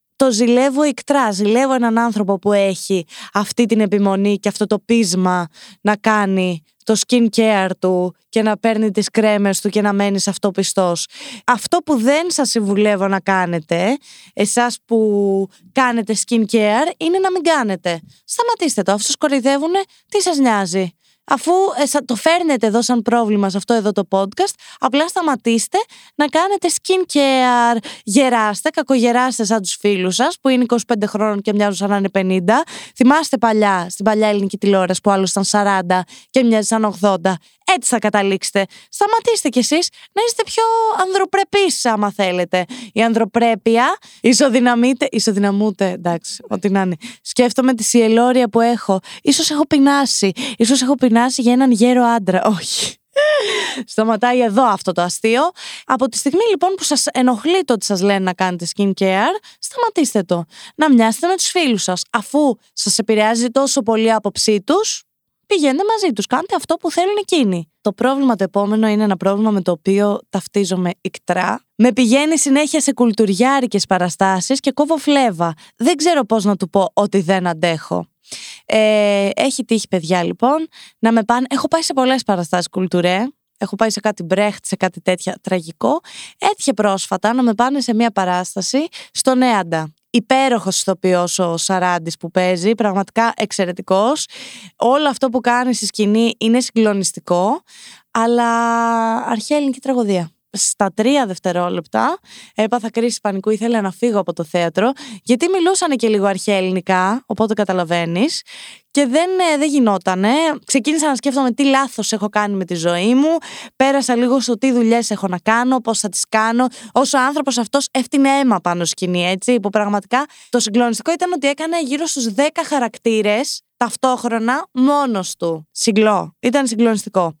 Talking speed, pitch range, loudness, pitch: 160 wpm, 200-270 Hz, -16 LUFS, 230 Hz